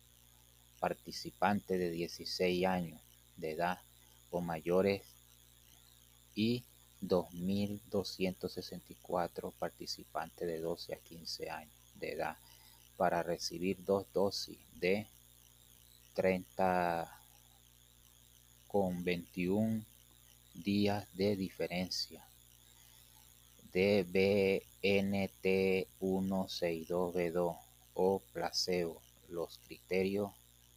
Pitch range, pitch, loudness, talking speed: 60-95 Hz, 85 Hz, -37 LUFS, 70 wpm